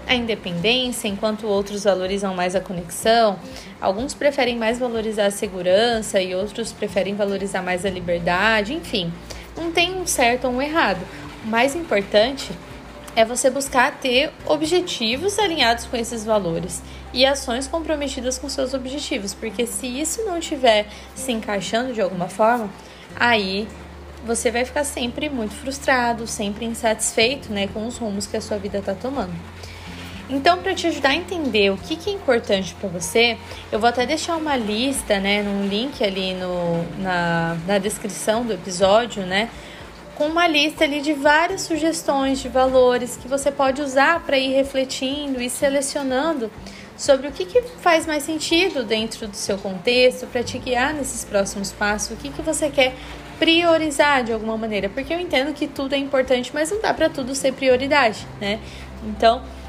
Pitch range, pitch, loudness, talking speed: 210-285 Hz, 245 Hz, -21 LUFS, 165 wpm